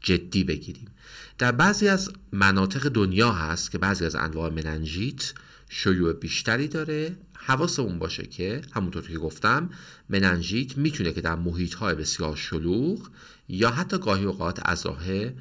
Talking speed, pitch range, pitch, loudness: 130 wpm, 85-140 Hz, 100 Hz, -26 LUFS